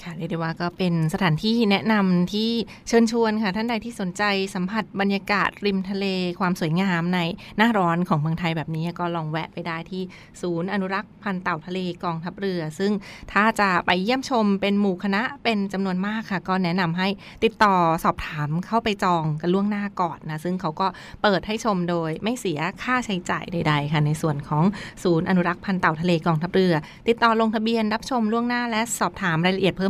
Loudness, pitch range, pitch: -23 LUFS, 170-210 Hz, 190 Hz